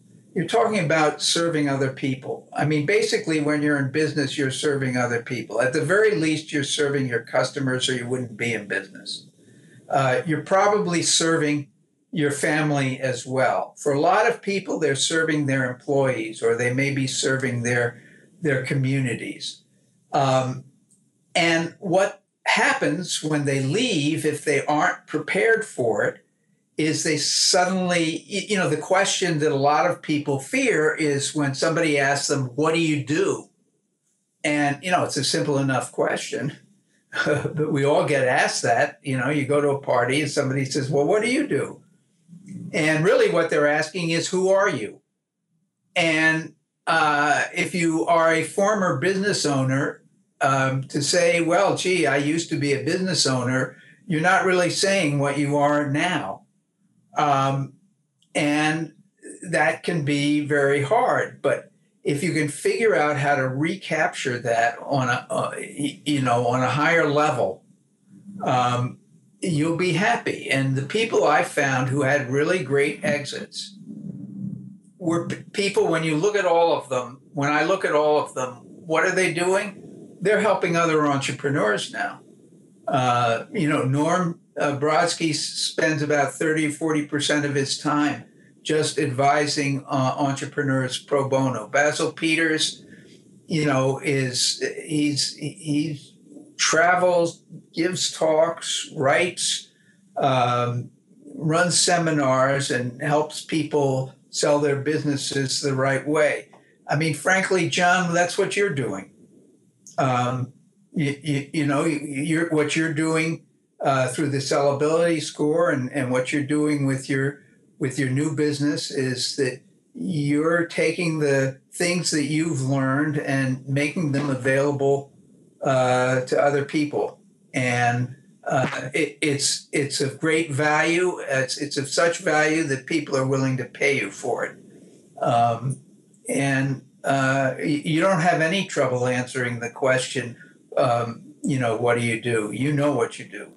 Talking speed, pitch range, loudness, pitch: 150 wpm, 140-170 Hz, -22 LUFS, 150 Hz